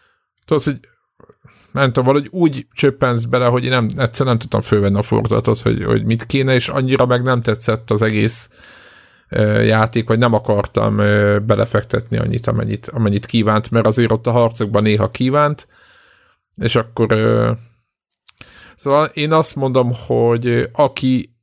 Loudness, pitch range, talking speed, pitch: -16 LUFS, 110-130 Hz, 155 wpm, 120 Hz